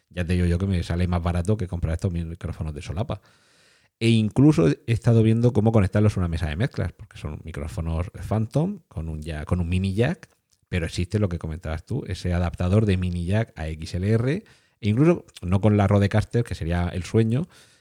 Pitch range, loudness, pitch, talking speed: 85-110 Hz, -24 LUFS, 95 Hz, 205 wpm